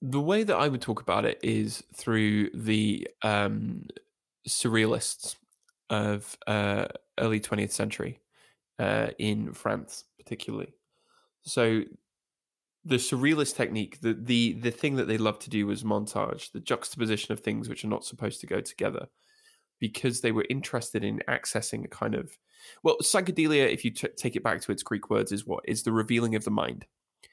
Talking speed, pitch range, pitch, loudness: 170 wpm, 105-140 Hz, 115 Hz, -29 LUFS